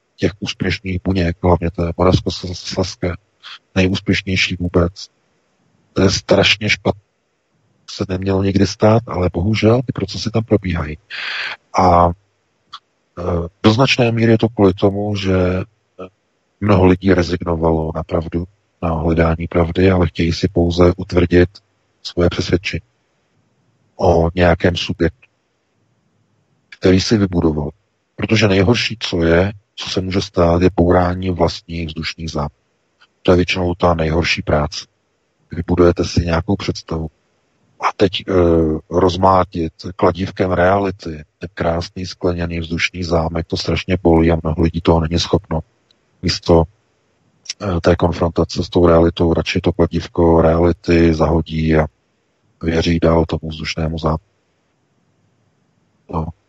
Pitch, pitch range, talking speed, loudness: 90 Hz, 85-95 Hz, 120 wpm, -16 LUFS